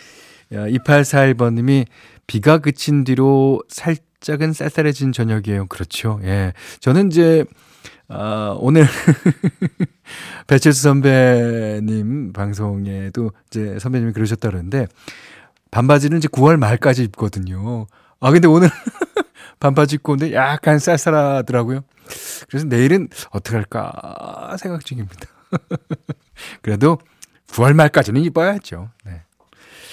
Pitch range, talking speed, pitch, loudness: 110-155 Hz, 240 characters per minute, 135 Hz, -16 LUFS